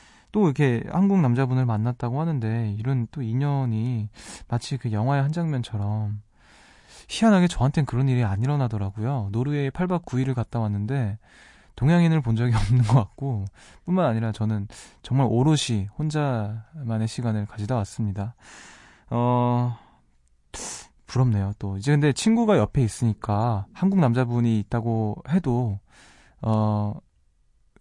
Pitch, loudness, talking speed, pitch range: 120 Hz, -24 LUFS, 290 characters per minute, 105-135 Hz